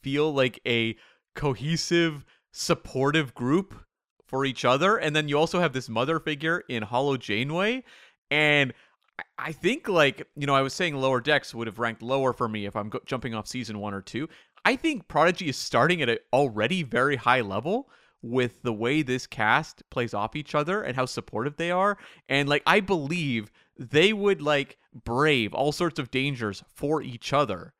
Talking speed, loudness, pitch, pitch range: 185 wpm, -26 LUFS, 135 Hz, 120-155 Hz